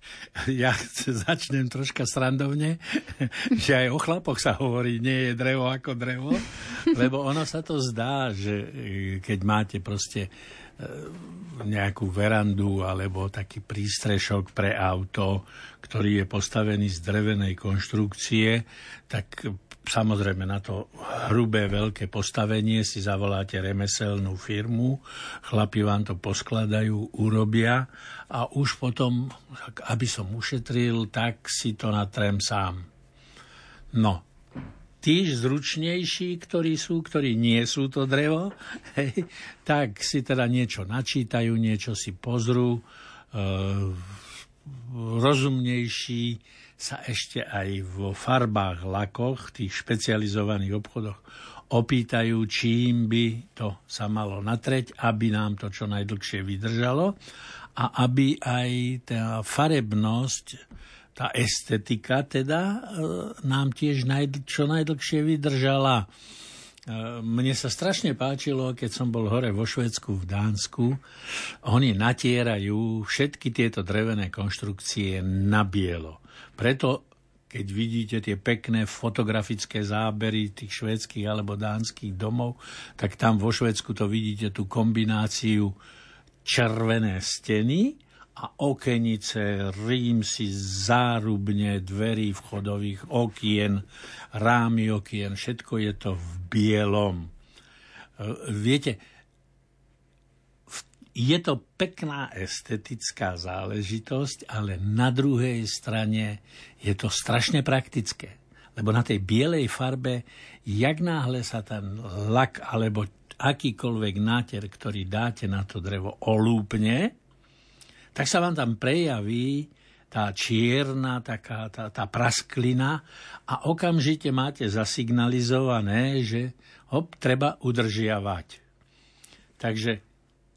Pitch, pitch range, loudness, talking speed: 115 Hz, 105-130 Hz, -27 LUFS, 105 wpm